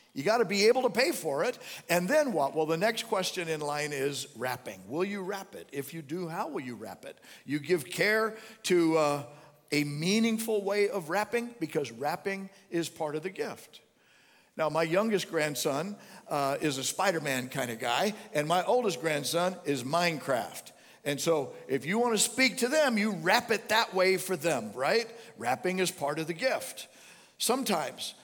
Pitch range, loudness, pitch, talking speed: 150-215 Hz, -30 LUFS, 175 Hz, 190 wpm